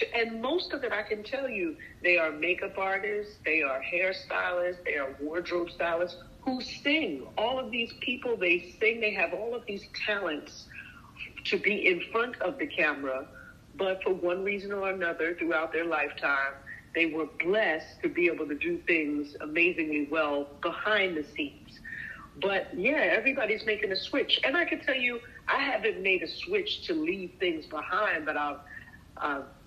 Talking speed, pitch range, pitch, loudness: 170 wpm, 160-240 Hz, 190 Hz, -29 LUFS